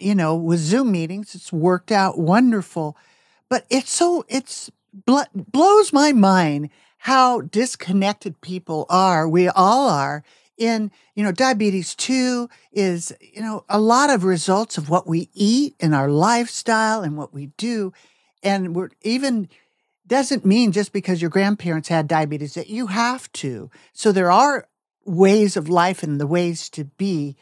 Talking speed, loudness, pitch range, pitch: 160 wpm, -19 LUFS, 170-235 Hz, 195 Hz